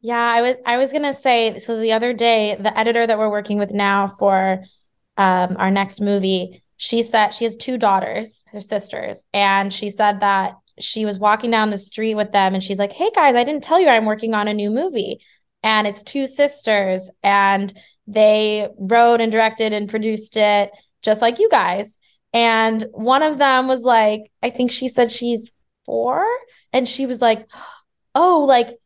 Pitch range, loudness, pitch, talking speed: 205-240 Hz, -18 LUFS, 220 Hz, 195 wpm